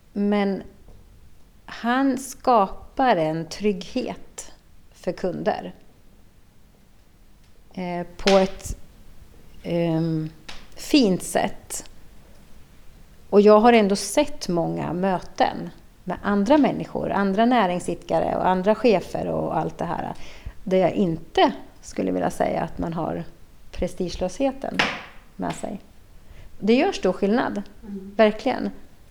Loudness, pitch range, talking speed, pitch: -23 LUFS, 165-225 Hz, 100 wpm, 195 Hz